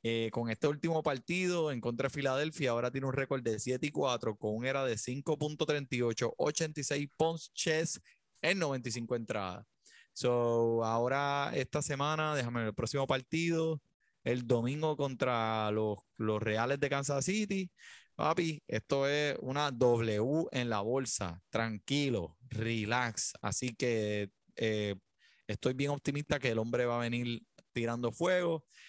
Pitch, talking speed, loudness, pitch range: 130 Hz, 145 wpm, -34 LUFS, 115-145 Hz